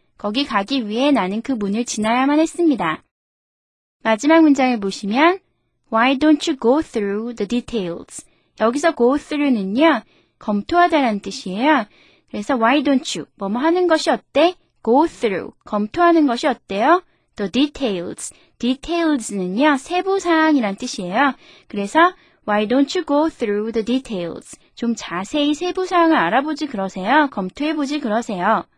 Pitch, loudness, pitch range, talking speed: 265 Hz, -18 LUFS, 215-310 Hz, 430 characters per minute